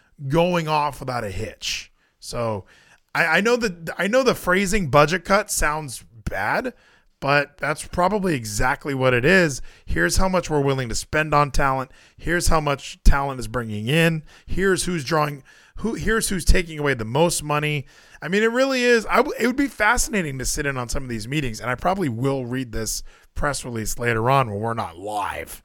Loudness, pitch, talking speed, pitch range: -22 LUFS, 150 Hz, 200 wpm, 130-180 Hz